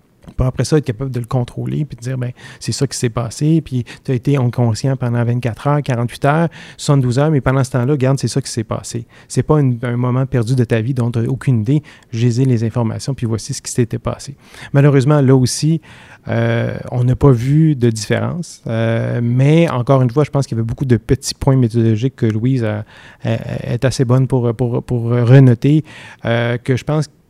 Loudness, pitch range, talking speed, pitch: -16 LUFS, 120-140 Hz, 230 wpm, 130 Hz